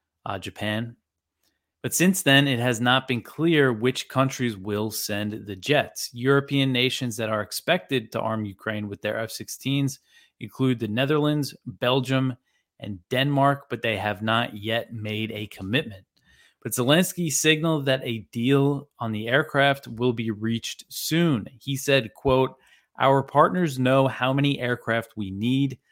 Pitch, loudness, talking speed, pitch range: 125 Hz, -24 LUFS, 150 wpm, 110-140 Hz